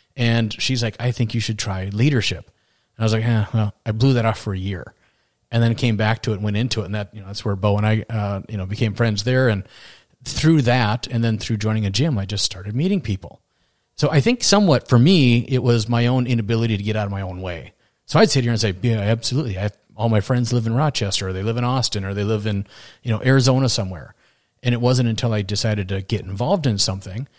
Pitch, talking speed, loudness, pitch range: 115 Hz, 260 wpm, -20 LUFS, 105-125 Hz